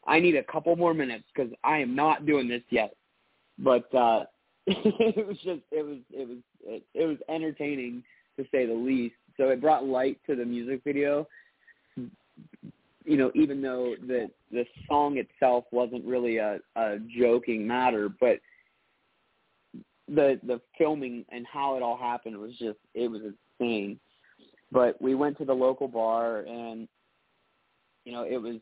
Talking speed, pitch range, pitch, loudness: 165 wpm, 120-145 Hz, 125 Hz, -28 LUFS